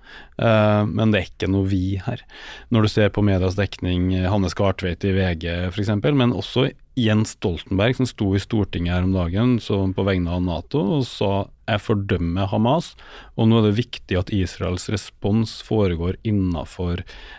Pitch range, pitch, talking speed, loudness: 90-110 Hz, 100 Hz, 175 wpm, -21 LUFS